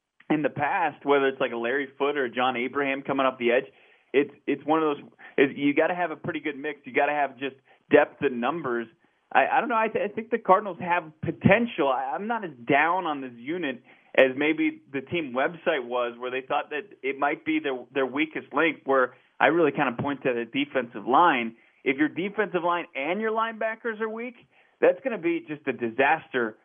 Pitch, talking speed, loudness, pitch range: 150 Hz, 225 wpm, -26 LUFS, 135-205 Hz